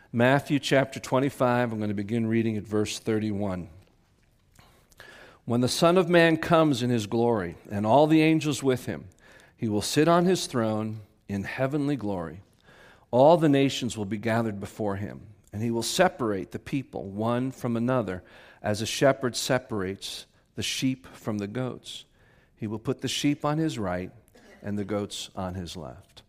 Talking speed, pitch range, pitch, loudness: 170 wpm, 105-135 Hz, 115 Hz, -26 LUFS